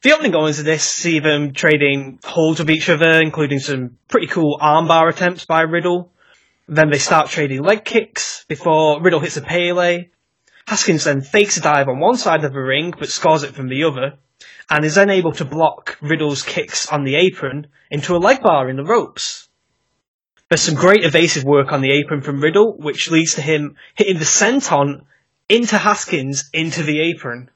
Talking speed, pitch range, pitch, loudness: 190 wpm, 145-175 Hz, 160 Hz, -16 LUFS